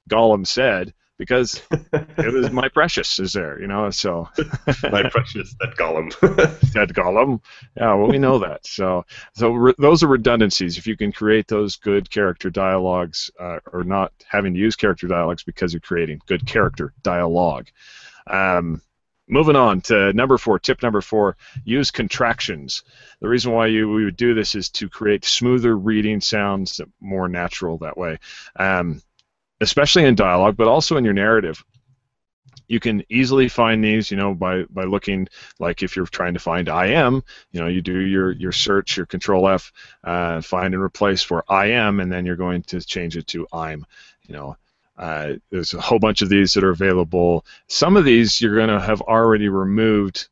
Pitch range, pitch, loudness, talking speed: 90-115 Hz, 100 Hz, -19 LUFS, 180 wpm